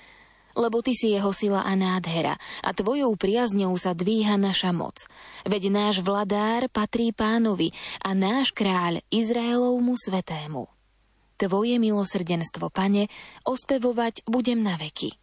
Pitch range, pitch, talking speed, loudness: 185-230 Hz, 205 Hz, 120 wpm, -25 LUFS